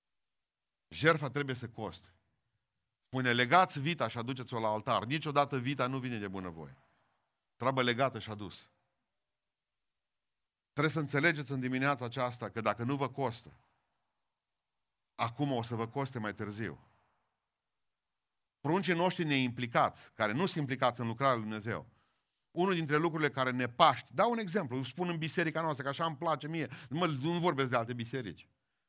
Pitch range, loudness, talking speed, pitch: 115-155 Hz, -33 LUFS, 155 wpm, 135 Hz